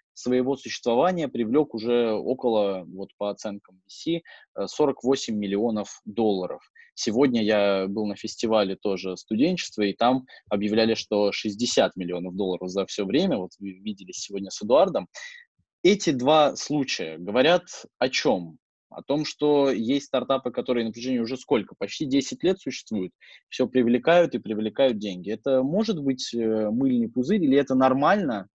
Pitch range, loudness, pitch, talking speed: 100-135 Hz, -25 LUFS, 115 Hz, 145 wpm